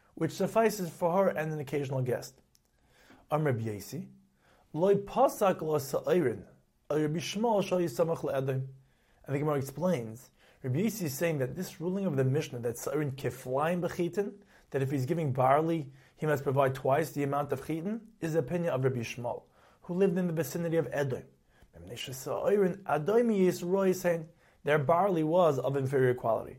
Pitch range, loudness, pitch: 135-180 Hz, -31 LUFS, 155 Hz